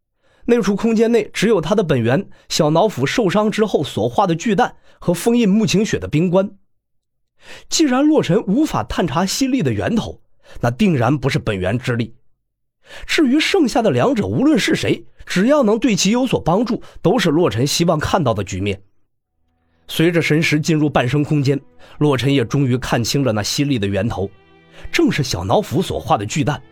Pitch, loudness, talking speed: 155 Hz, -17 LUFS, 265 characters per minute